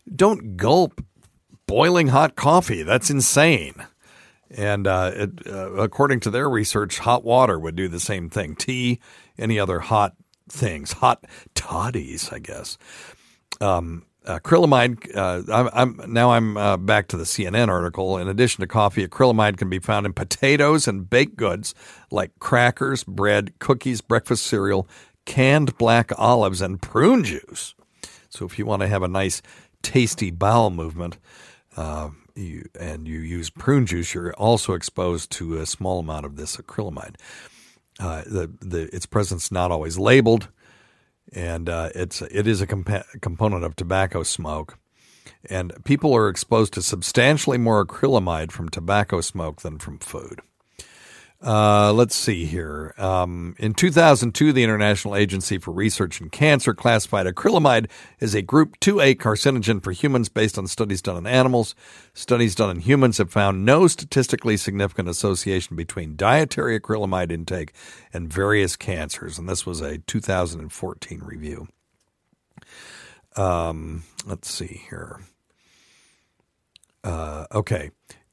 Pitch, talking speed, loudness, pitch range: 100 Hz, 145 wpm, -21 LUFS, 90-120 Hz